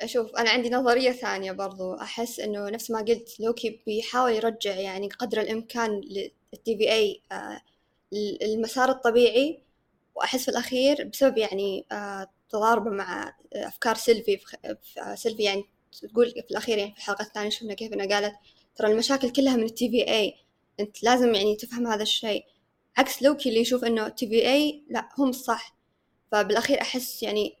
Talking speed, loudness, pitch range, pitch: 165 wpm, -26 LUFS, 210-250 Hz, 230 Hz